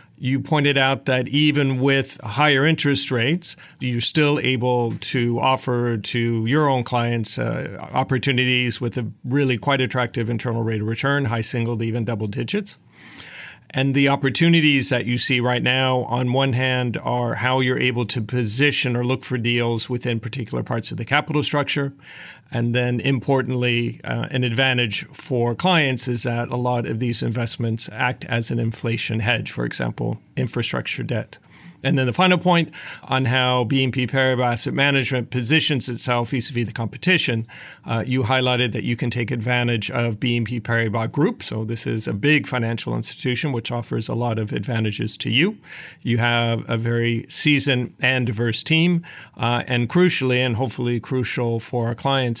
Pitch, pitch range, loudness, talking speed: 125 Hz, 120-135 Hz, -20 LUFS, 170 wpm